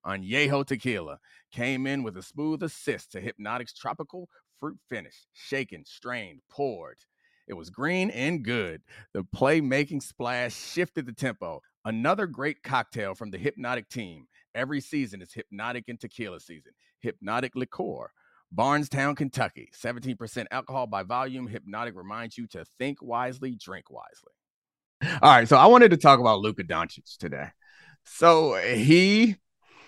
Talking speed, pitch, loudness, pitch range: 145 wpm, 130 Hz, -25 LUFS, 120-150 Hz